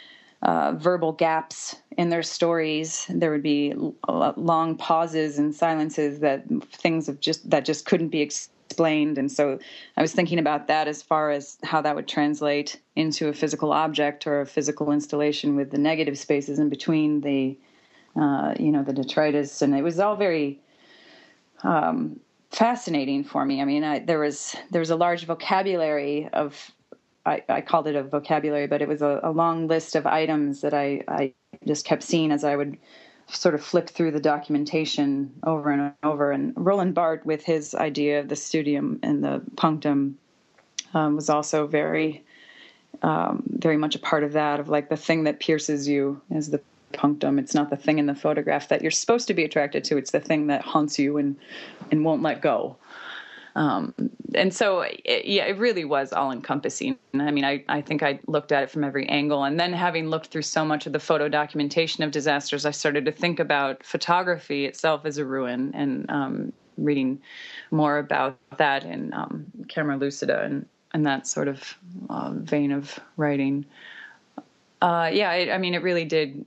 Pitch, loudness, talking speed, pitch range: 150 Hz, -24 LUFS, 190 wpm, 145-165 Hz